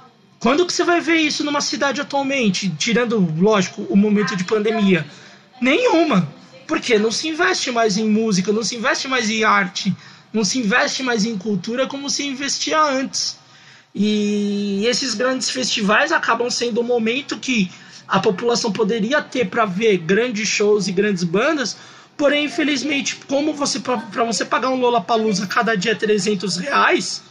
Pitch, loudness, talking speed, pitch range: 230 Hz, -18 LUFS, 165 wpm, 205-270 Hz